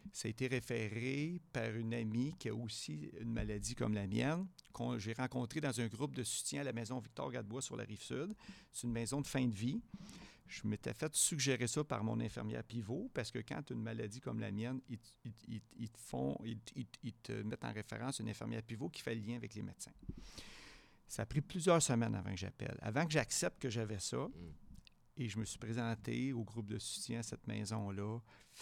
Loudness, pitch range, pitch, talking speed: -41 LUFS, 110-130 Hz, 115 Hz, 220 wpm